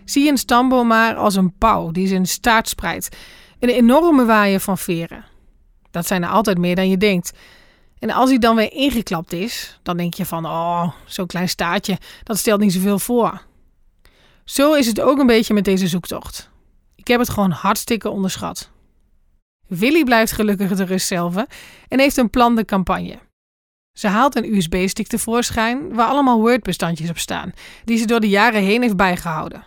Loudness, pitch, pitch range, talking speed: -17 LUFS, 205 Hz, 185-235 Hz, 180 wpm